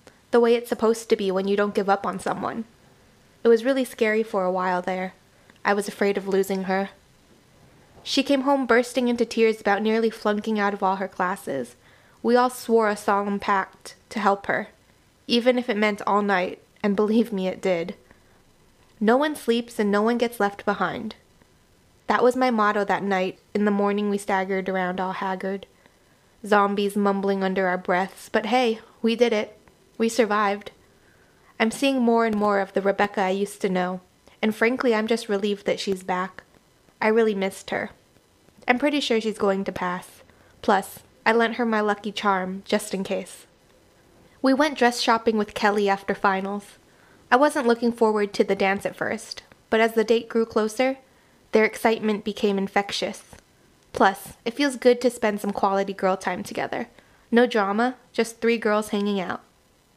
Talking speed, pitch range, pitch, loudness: 180 wpm, 195-230 Hz, 210 Hz, -23 LUFS